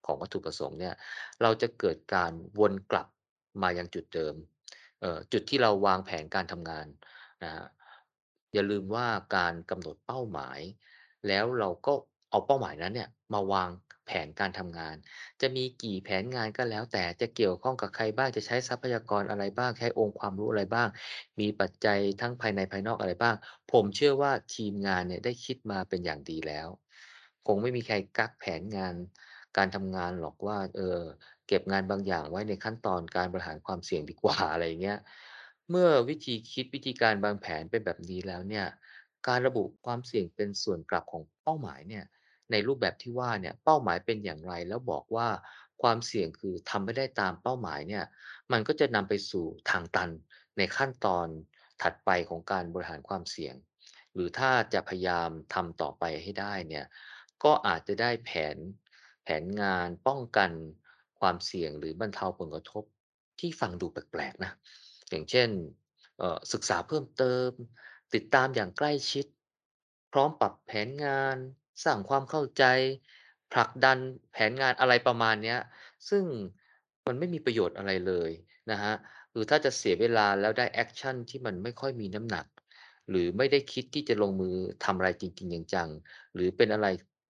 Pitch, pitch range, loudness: 105 Hz, 95-125 Hz, -31 LUFS